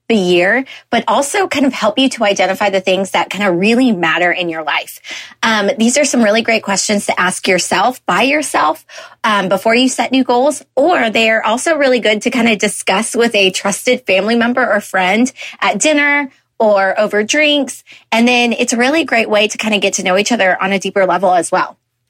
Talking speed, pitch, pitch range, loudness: 220 wpm, 225 Hz, 195-250 Hz, -13 LUFS